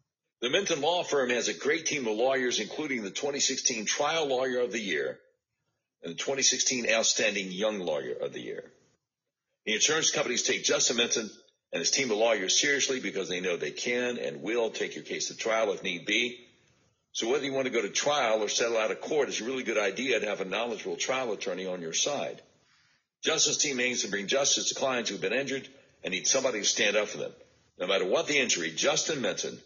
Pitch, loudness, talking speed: 135 Hz, -28 LUFS, 220 wpm